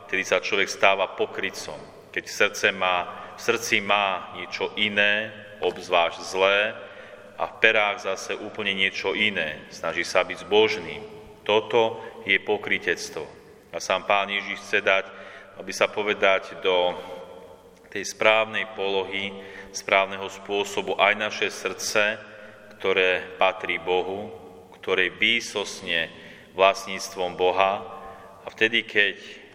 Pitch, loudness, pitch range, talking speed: 95 Hz, -24 LUFS, 95-105 Hz, 110 wpm